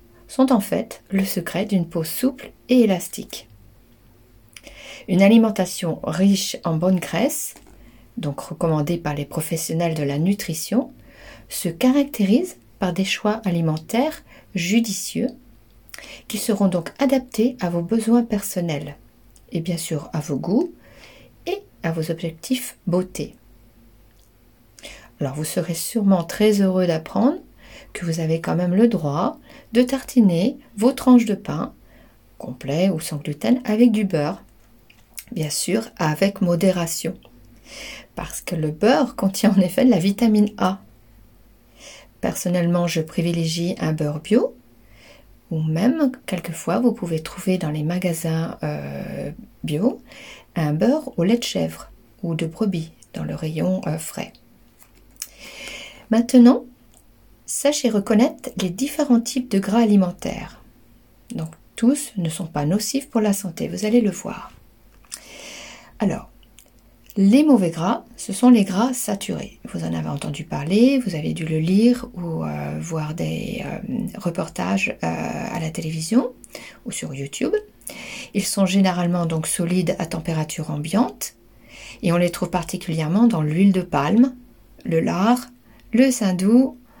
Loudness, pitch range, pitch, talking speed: -21 LUFS, 155-230 Hz, 185 Hz, 135 wpm